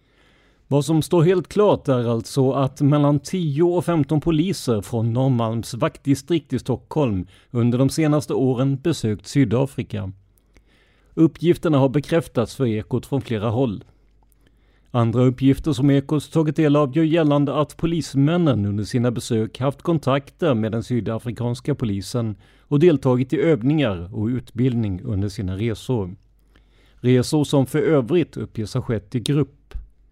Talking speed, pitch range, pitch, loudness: 140 wpm, 115-150 Hz, 130 Hz, -21 LUFS